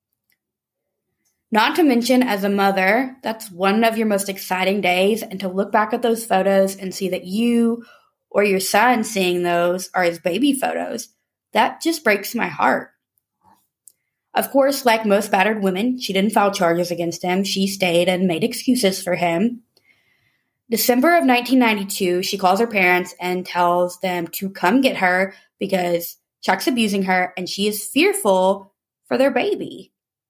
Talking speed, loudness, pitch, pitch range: 160 wpm, -19 LUFS, 195 Hz, 185-230 Hz